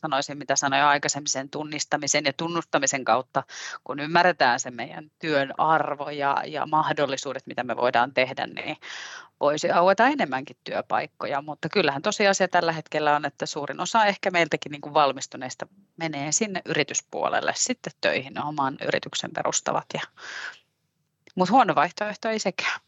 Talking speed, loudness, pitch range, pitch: 140 wpm, -24 LUFS, 140-175 Hz, 155 Hz